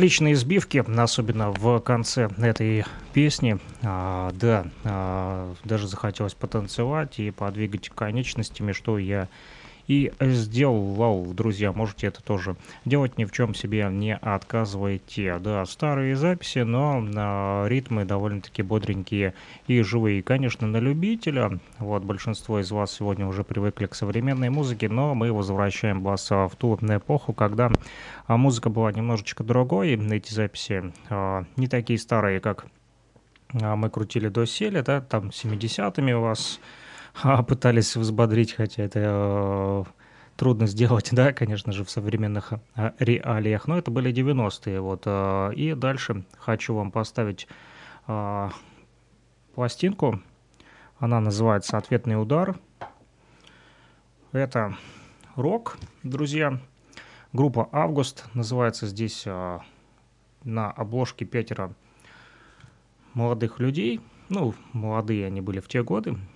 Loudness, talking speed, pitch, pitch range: -25 LUFS, 125 wpm, 110 Hz, 100-125 Hz